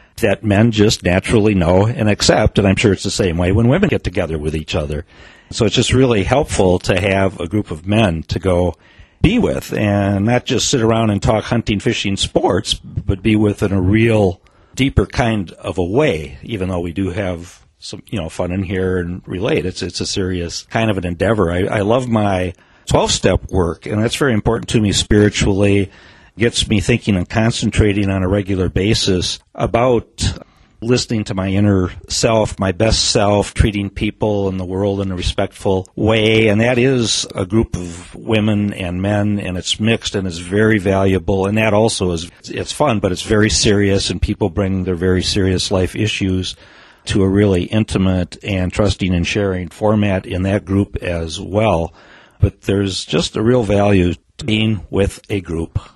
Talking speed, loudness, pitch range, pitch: 190 wpm, -16 LUFS, 90-110 Hz, 100 Hz